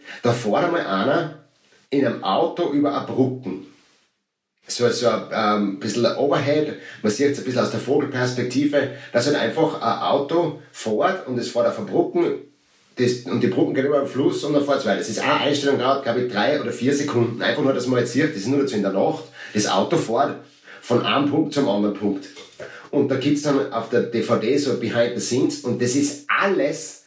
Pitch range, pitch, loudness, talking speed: 120-145 Hz, 135 Hz, -21 LUFS, 215 wpm